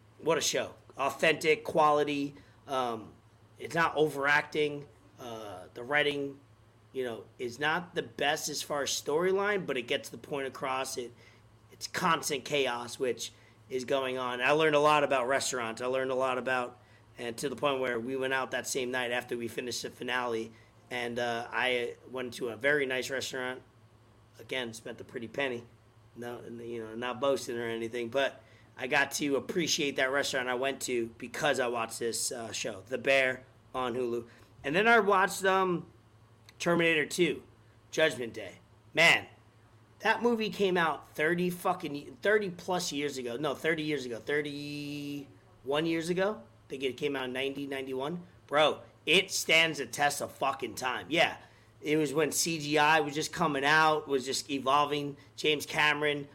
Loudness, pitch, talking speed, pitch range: -30 LUFS, 130 Hz, 170 wpm, 120-150 Hz